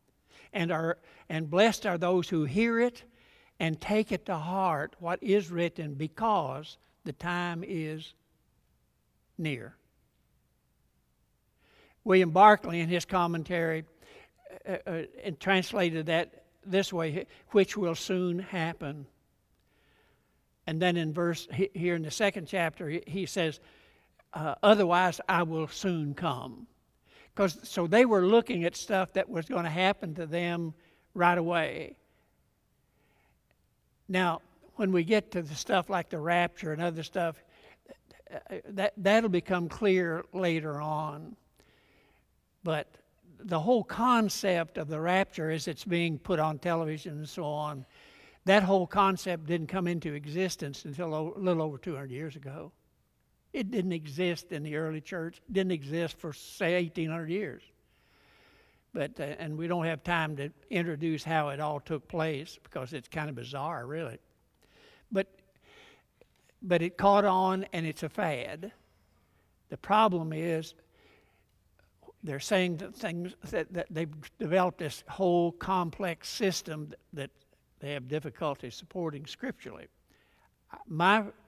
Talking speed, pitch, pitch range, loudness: 135 wpm, 170 Hz, 155-185 Hz, -30 LUFS